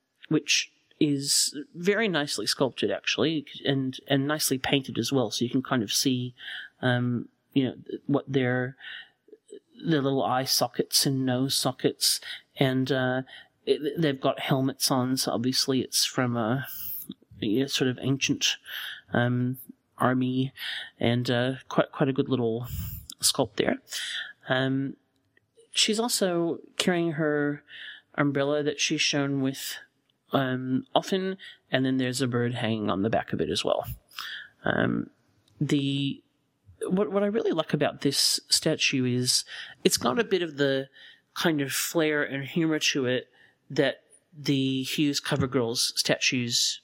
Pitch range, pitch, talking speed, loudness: 130-150 Hz, 135 Hz, 145 wpm, -26 LUFS